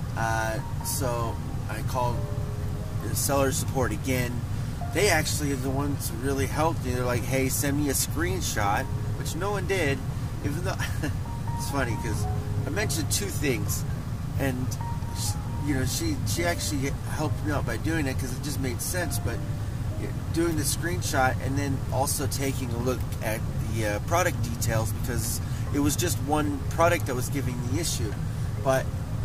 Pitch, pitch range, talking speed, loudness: 120 Hz, 105-130 Hz, 170 wpm, -28 LUFS